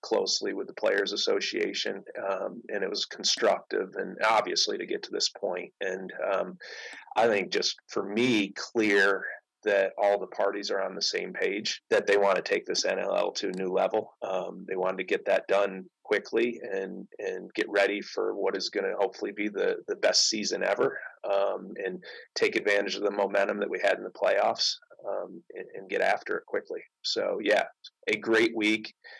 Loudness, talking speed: -28 LUFS, 195 wpm